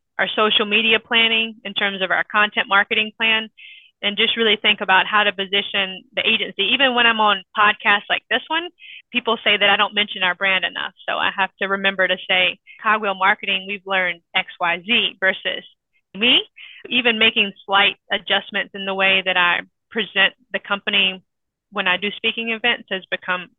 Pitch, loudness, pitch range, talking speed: 205 Hz, -18 LUFS, 195-225 Hz, 185 wpm